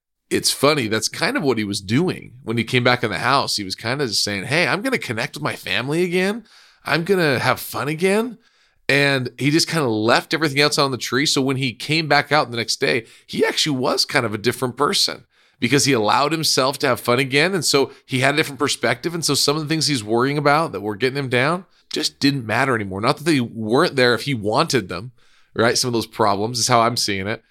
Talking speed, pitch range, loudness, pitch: 250 wpm, 115-150 Hz, -19 LUFS, 135 Hz